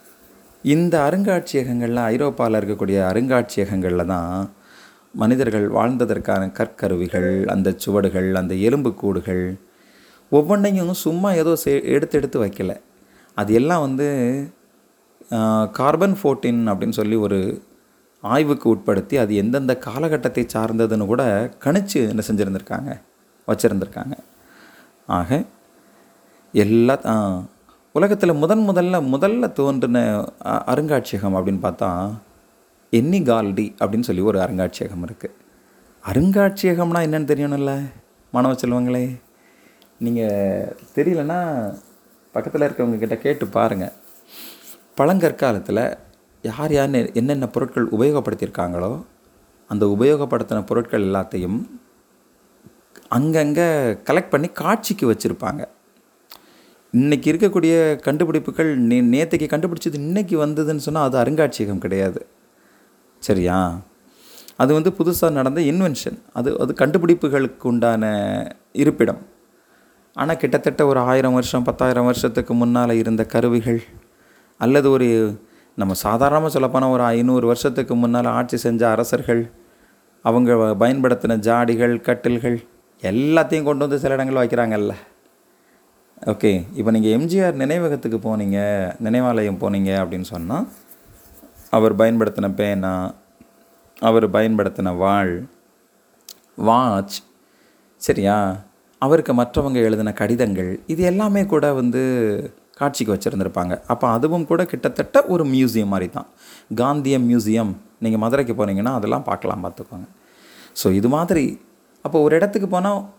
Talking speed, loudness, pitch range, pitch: 100 wpm, -19 LUFS, 105-150 Hz, 120 Hz